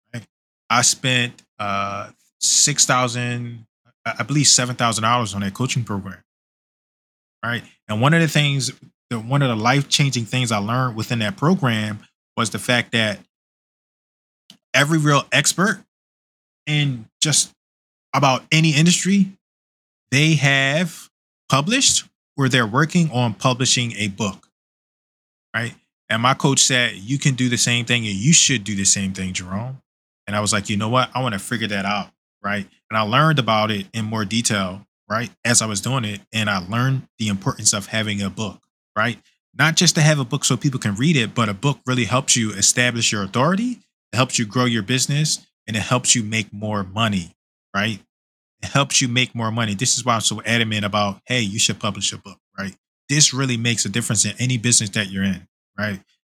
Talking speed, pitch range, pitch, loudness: 190 wpm, 105-135 Hz, 120 Hz, -19 LUFS